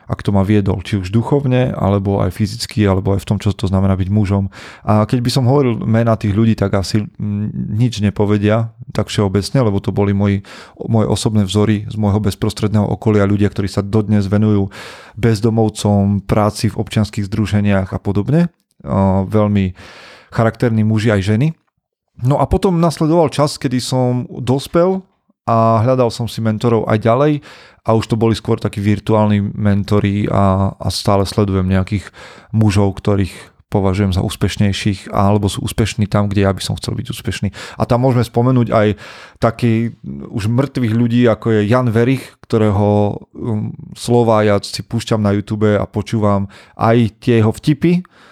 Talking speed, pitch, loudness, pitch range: 160 wpm, 105 Hz, -16 LUFS, 100-115 Hz